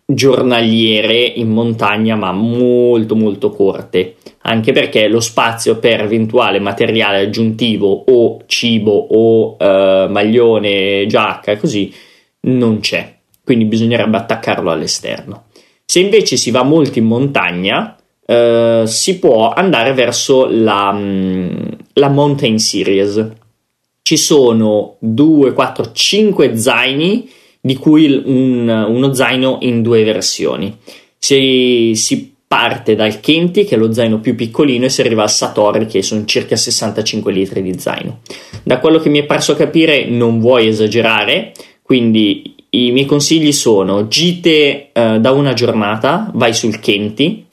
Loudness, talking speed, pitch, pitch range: -12 LUFS, 135 wpm, 115 Hz, 110-130 Hz